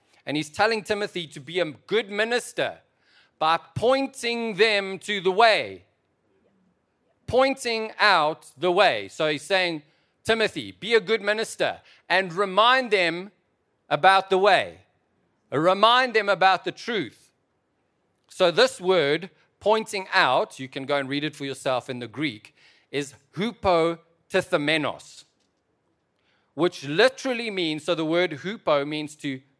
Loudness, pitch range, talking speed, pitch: -23 LUFS, 150-210 Hz, 135 wpm, 180 Hz